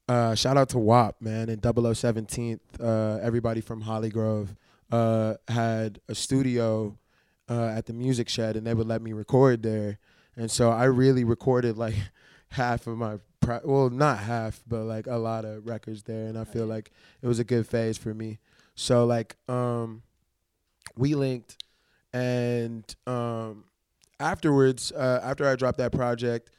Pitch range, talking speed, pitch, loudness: 110-125 Hz, 165 wpm, 115 Hz, -27 LUFS